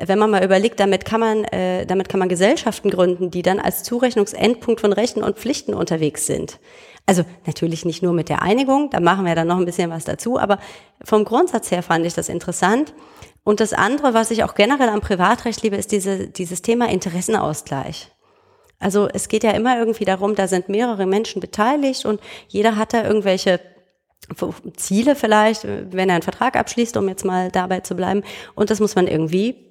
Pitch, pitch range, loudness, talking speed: 200 Hz, 185-225 Hz, -19 LUFS, 195 wpm